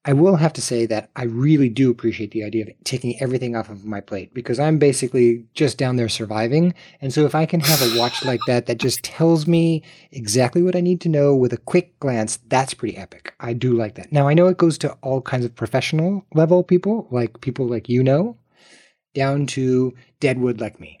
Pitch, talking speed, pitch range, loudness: 130 Hz, 225 wpm, 120-155 Hz, -19 LUFS